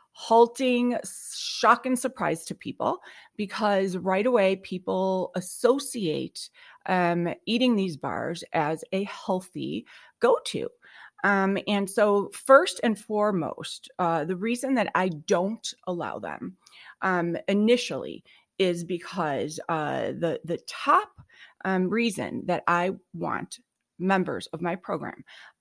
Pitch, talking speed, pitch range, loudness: 195 Hz, 115 wpm, 180-245 Hz, -26 LUFS